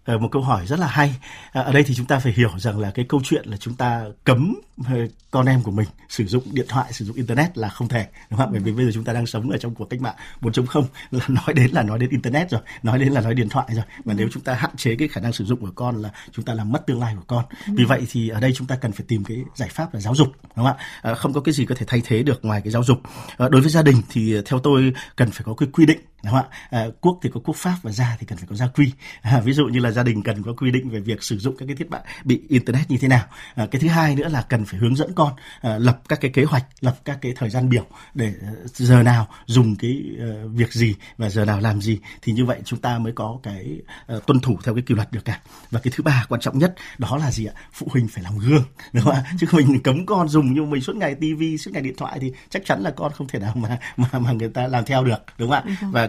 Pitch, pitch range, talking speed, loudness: 125 Hz, 115-140 Hz, 300 wpm, -21 LUFS